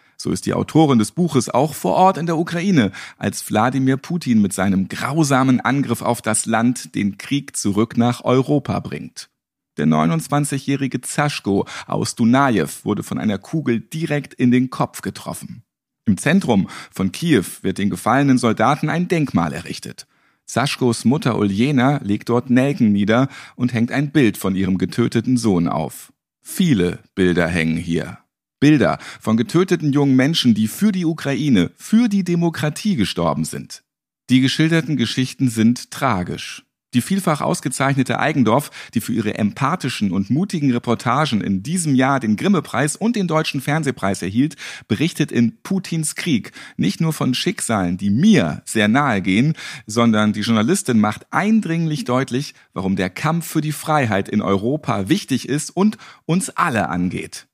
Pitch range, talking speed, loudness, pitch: 110-155 Hz, 150 wpm, -19 LUFS, 130 Hz